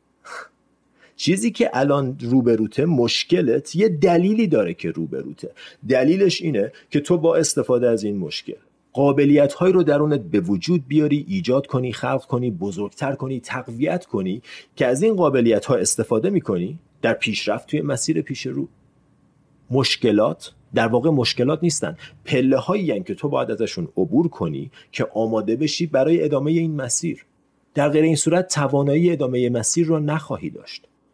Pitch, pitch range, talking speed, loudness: 145 Hz, 125-165 Hz, 150 wpm, -20 LUFS